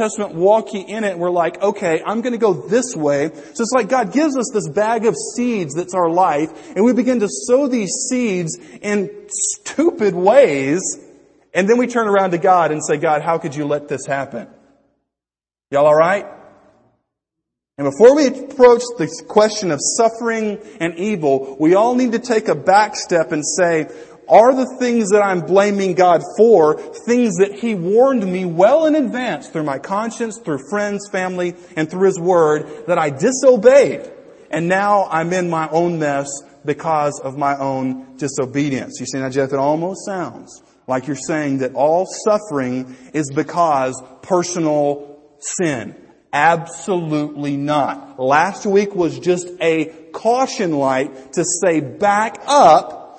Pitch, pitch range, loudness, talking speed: 185 Hz, 150-220 Hz, -17 LUFS, 165 wpm